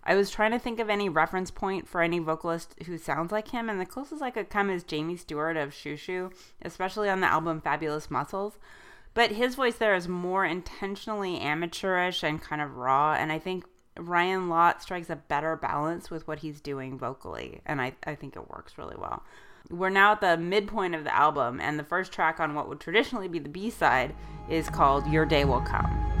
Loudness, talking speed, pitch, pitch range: -28 LUFS, 215 wpm, 175 Hz, 155-195 Hz